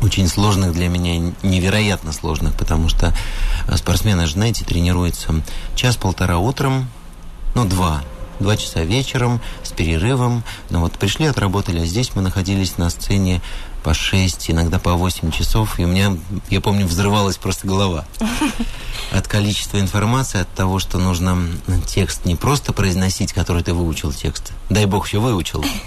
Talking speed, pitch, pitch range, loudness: 145 wpm, 95 Hz, 85-105 Hz, -19 LUFS